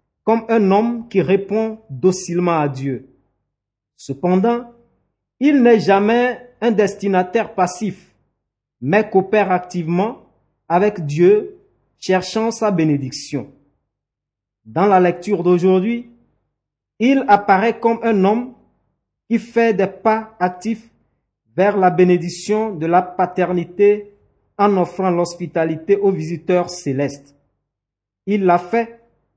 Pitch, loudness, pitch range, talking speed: 185 Hz, -17 LUFS, 160-220 Hz, 105 wpm